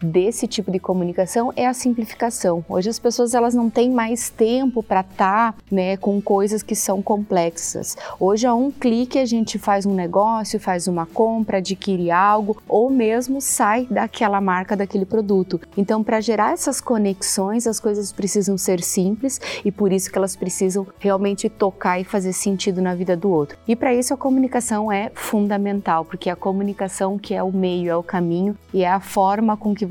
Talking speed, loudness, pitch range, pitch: 185 wpm, -20 LUFS, 190-225 Hz, 205 Hz